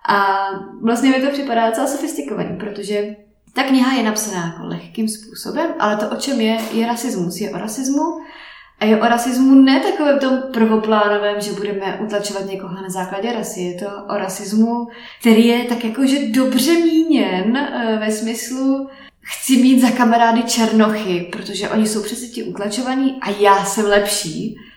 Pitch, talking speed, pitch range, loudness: 225 Hz, 165 wpm, 205-260 Hz, -17 LUFS